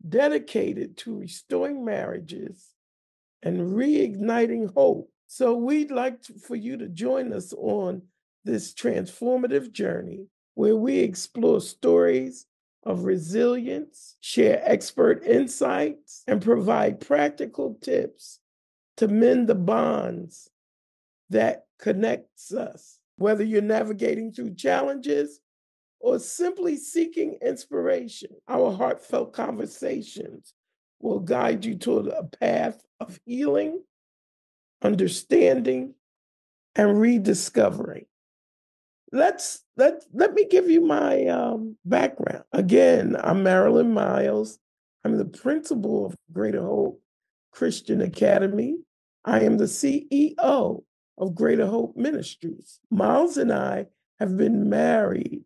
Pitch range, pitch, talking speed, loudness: 185-280 Hz, 225 Hz, 105 wpm, -24 LUFS